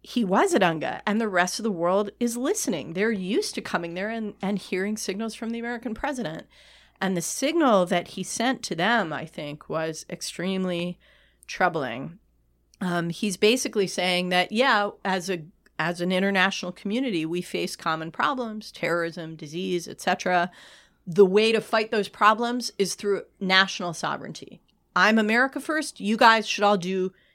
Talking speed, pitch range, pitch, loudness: 165 wpm, 180-225 Hz, 195 Hz, -25 LUFS